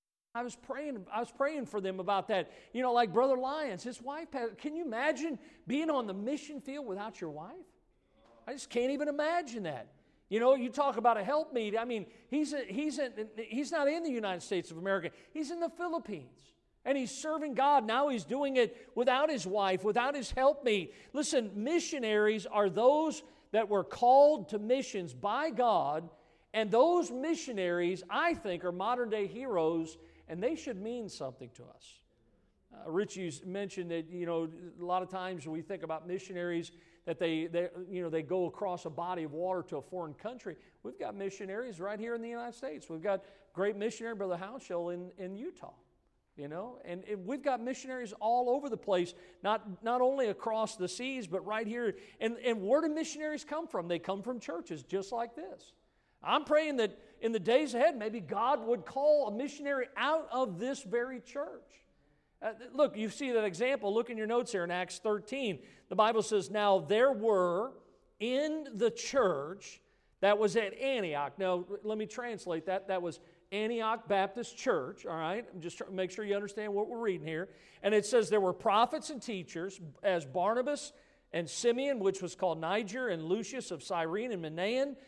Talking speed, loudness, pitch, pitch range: 195 wpm, -34 LUFS, 220 Hz, 185-265 Hz